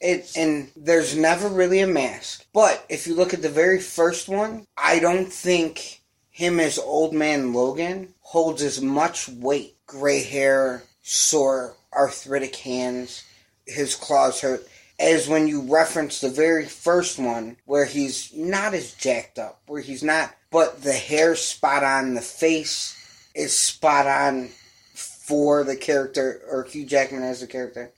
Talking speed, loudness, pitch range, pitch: 155 wpm, -22 LUFS, 135-165 Hz, 145 Hz